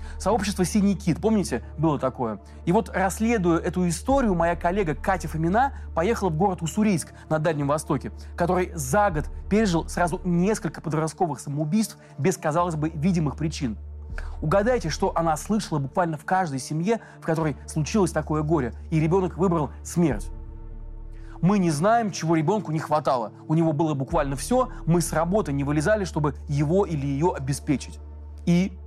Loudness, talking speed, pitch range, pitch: -24 LUFS, 155 wpm, 145-190 Hz, 165 Hz